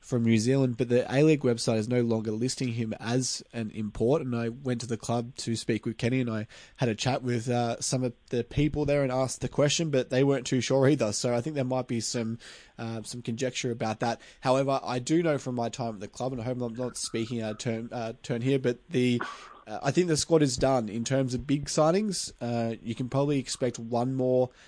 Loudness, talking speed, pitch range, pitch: -28 LUFS, 250 wpm, 115-135 Hz, 125 Hz